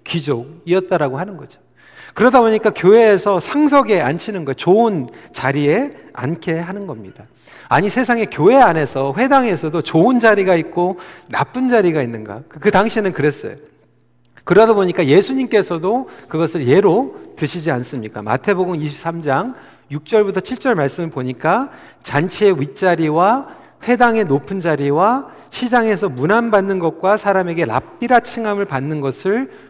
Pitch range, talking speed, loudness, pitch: 145-215 Hz, 320 characters per minute, -16 LUFS, 180 Hz